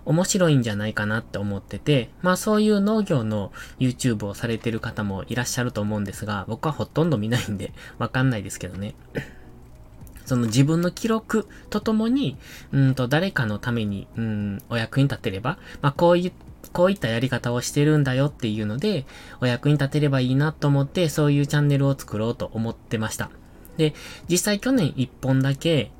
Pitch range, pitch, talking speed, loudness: 110-150 Hz, 130 Hz, 395 characters per minute, -23 LUFS